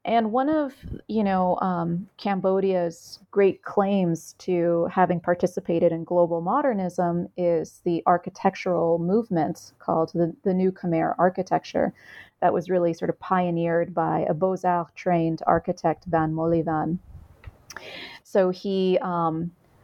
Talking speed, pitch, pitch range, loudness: 120 wpm, 180 Hz, 170-190 Hz, -24 LUFS